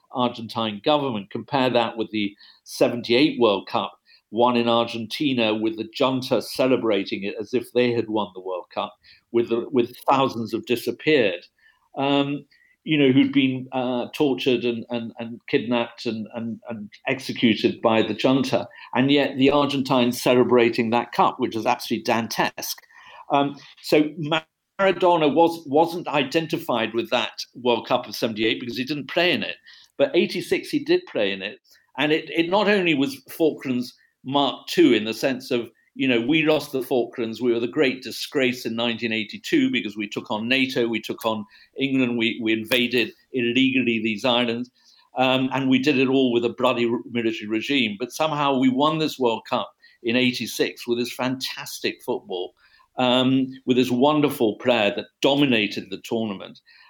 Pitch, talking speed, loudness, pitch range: 125 Hz, 165 wpm, -22 LUFS, 115-145 Hz